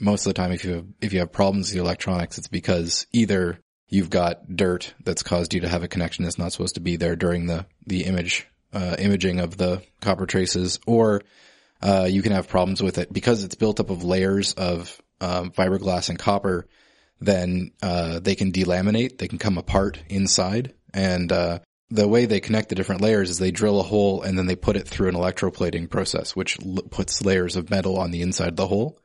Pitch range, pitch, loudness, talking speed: 90-100 Hz, 95 Hz, -23 LUFS, 220 wpm